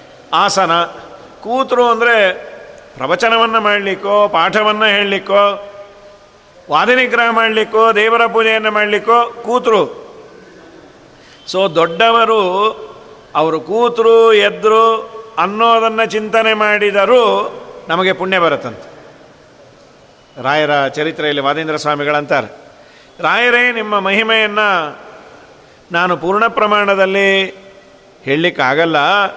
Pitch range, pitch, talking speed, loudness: 190-230 Hz, 210 Hz, 70 wpm, -12 LUFS